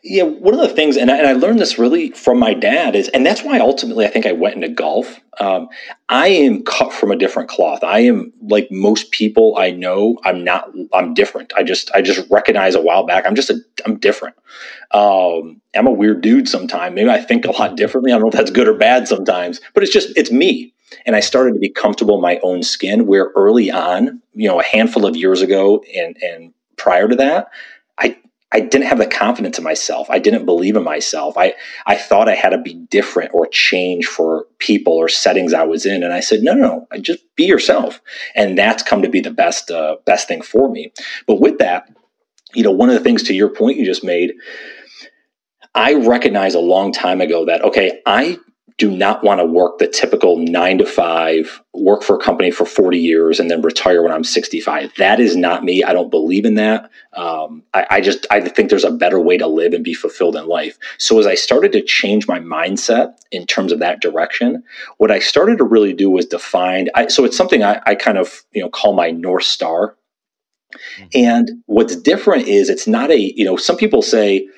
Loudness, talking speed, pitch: -14 LUFS, 225 wpm, 220 Hz